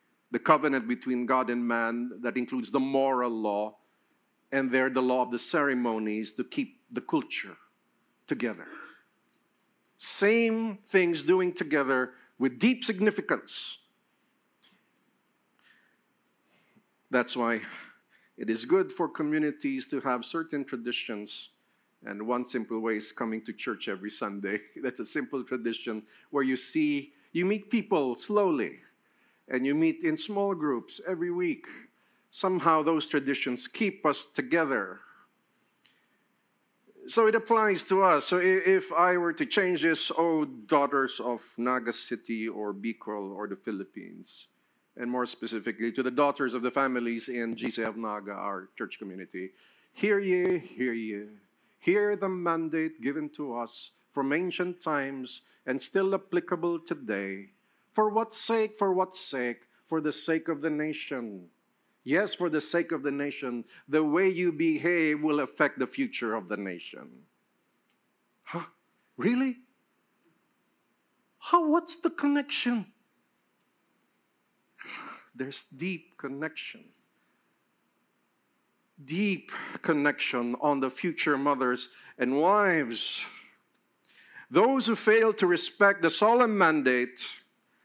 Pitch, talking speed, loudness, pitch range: 150 Hz, 125 wpm, -29 LUFS, 125-200 Hz